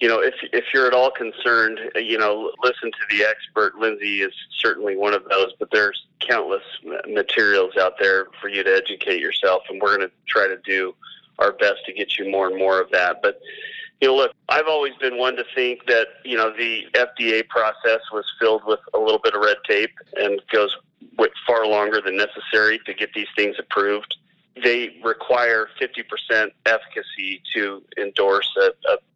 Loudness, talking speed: -20 LUFS, 190 wpm